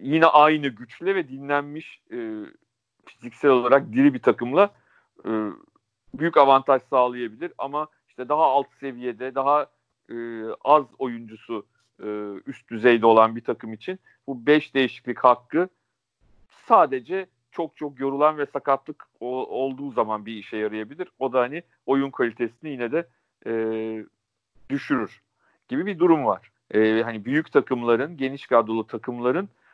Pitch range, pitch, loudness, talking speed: 115-150 Hz, 135 Hz, -23 LUFS, 135 wpm